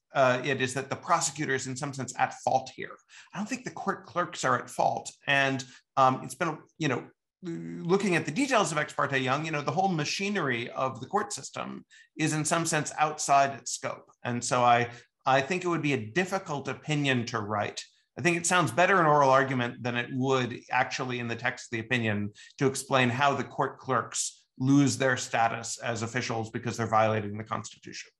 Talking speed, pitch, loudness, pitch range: 210 wpm, 135 Hz, -28 LUFS, 120-155 Hz